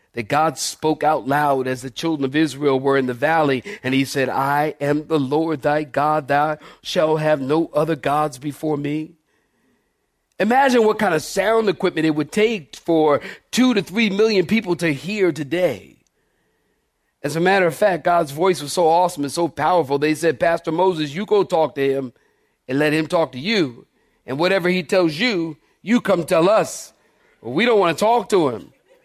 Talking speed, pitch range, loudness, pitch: 190 wpm, 145-180 Hz, -19 LUFS, 155 Hz